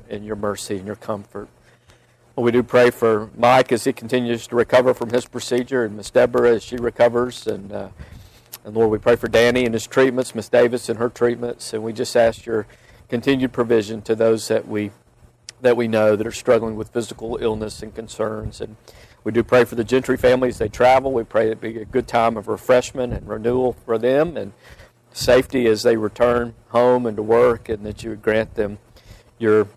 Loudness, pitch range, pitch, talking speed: -19 LUFS, 110-125 Hz, 115 Hz, 210 wpm